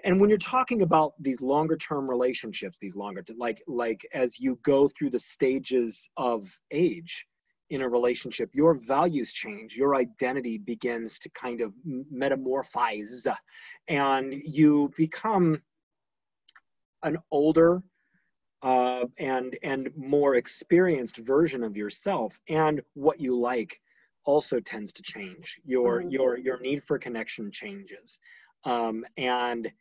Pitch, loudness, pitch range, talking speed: 135 Hz, -27 LUFS, 120-155 Hz, 130 wpm